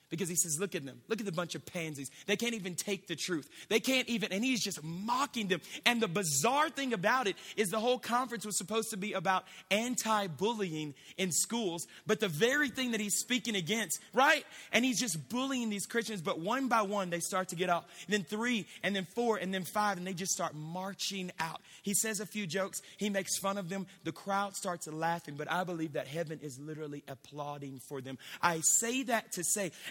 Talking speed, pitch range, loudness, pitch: 225 wpm, 170-220 Hz, -33 LUFS, 195 Hz